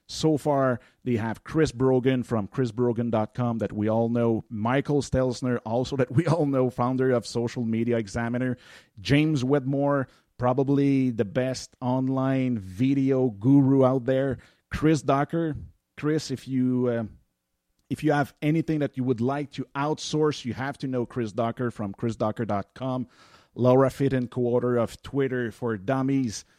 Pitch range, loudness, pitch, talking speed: 115-135 Hz, -26 LUFS, 125 Hz, 145 wpm